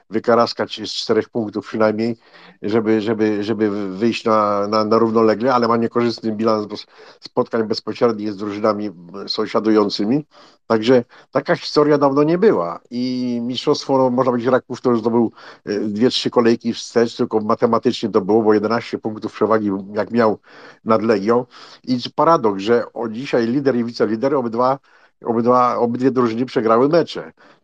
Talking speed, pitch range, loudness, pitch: 150 wpm, 110-125 Hz, -18 LUFS, 115 Hz